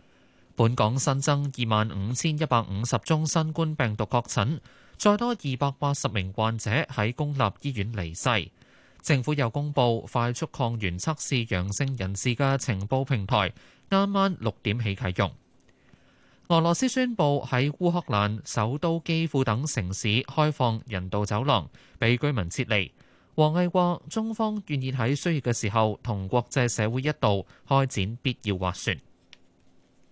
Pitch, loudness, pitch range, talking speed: 125 Hz, -26 LUFS, 105-145 Hz, 230 characters per minute